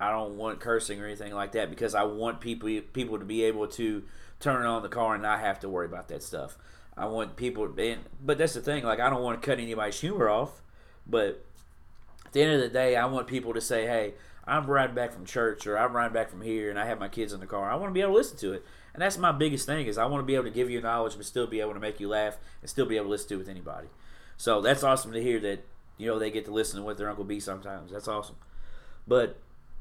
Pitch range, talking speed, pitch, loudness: 105-125 Hz, 285 wpm, 110 Hz, -30 LUFS